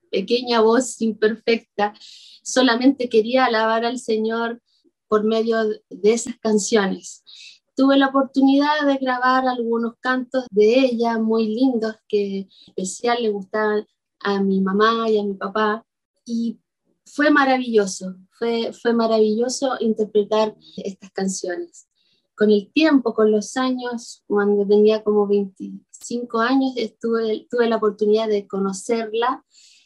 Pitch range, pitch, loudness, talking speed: 210-245 Hz, 225 Hz, -20 LUFS, 125 wpm